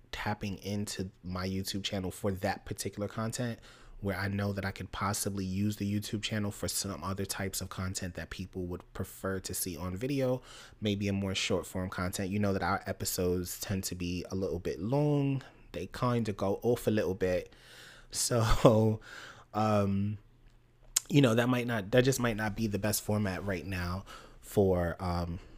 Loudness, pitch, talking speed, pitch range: -33 LUFS, 100 Hz, 185 wpm, 95-110 Hz